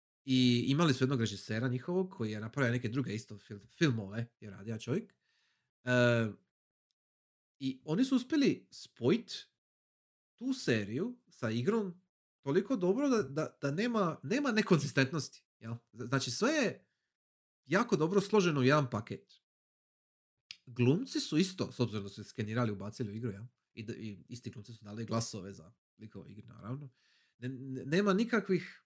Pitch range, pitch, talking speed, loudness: 110-170 Hz, 125 Hz, 145 wpm, -33 LUFS